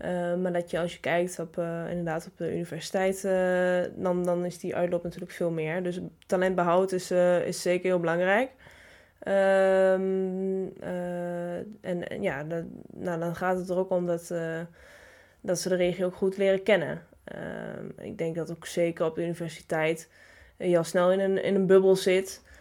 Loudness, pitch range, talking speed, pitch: -28 LUFS, 170-190 Hz, 190 wpm, 180 Hz